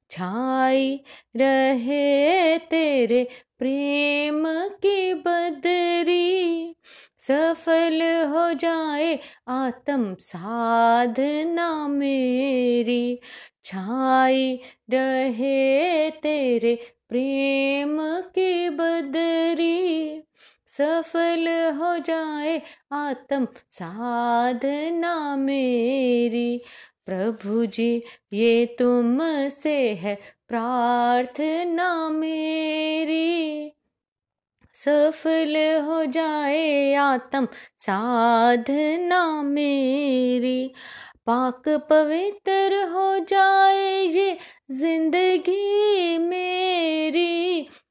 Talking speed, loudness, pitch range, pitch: 55 wpm, -22 LUFS, 255-330 Hz, 295 Hz